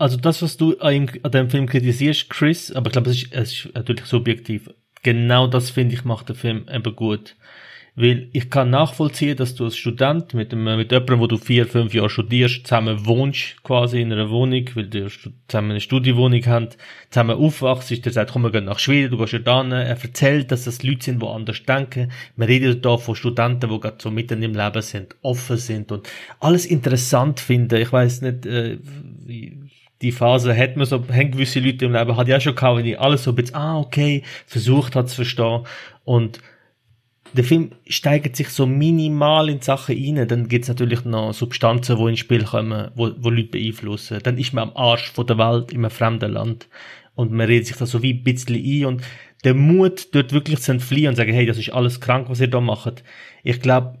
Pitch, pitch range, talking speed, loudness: 125 Hz, 115-135 Hz, 215 wpm, -19 LUFS